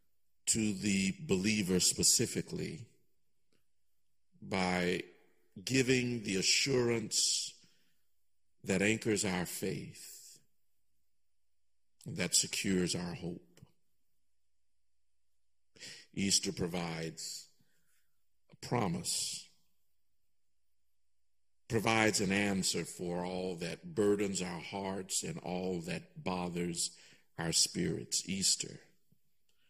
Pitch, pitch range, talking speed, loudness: 90 Hz, 65-100 Hz, 75 wpm, -33 LUFS